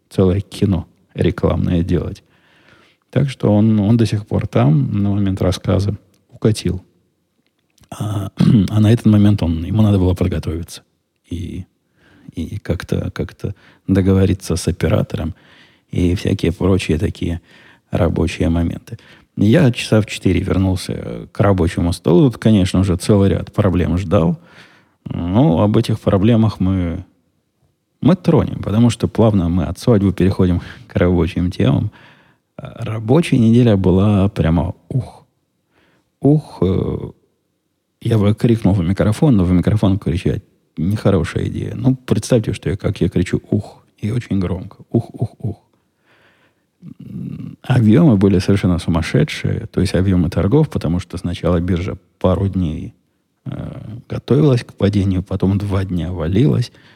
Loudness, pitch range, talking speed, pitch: -16 LUFS, 90-110 Hz, 130 wpm, 100 Hz